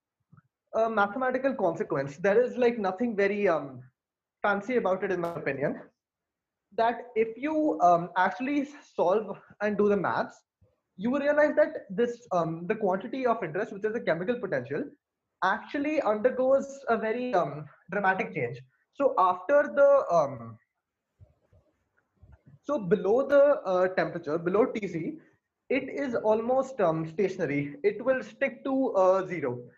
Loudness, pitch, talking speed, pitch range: -27 LUFS, 210 Hz, 140 wpm, 175-255 Hz